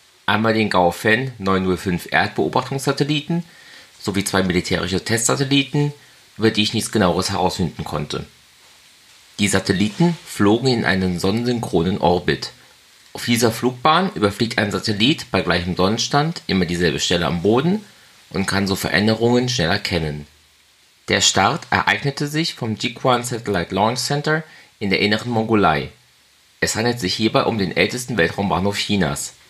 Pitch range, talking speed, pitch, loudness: 95-125 Hz, 135 wpm, 105 Hz, -19 LUFS